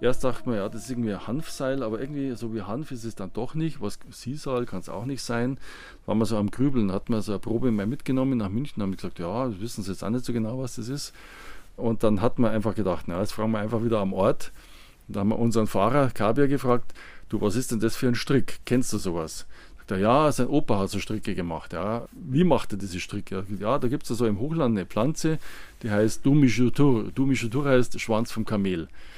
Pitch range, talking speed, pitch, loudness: 105-130 Hz, 245 wpm, 115 Hz, -27 LUFS